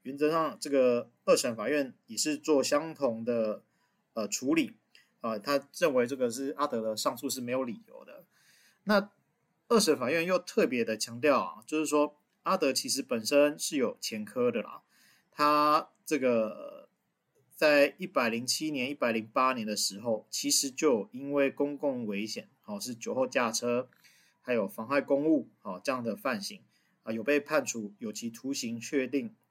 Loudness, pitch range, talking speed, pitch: -30 LUFS, 120-200 Hz, 245 characters per minute, 145 Hz